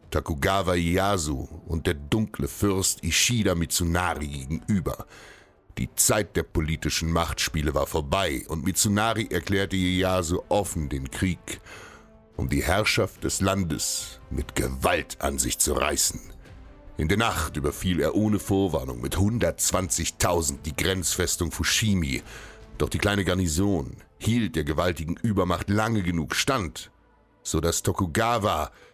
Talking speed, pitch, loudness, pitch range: 125 wpm, 90 Hz, -25 LUFS, 80-100 Hz